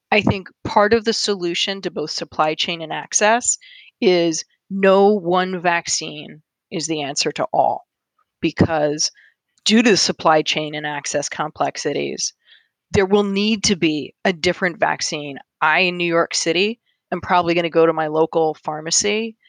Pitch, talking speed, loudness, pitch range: 175 Hz, 160 wpm, -19 LUFS, 160-205 Hz